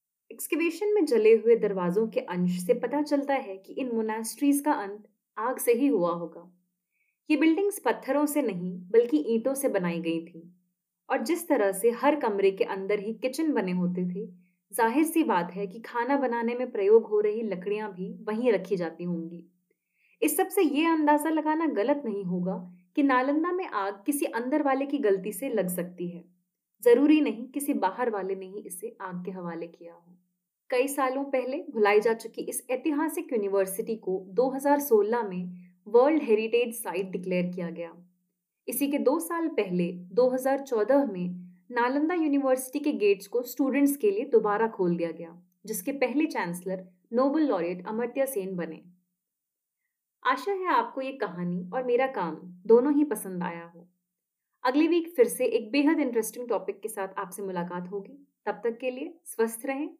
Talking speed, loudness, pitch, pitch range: 175 wpm, -27 LUFS, 230 Hz, 185-285 Hz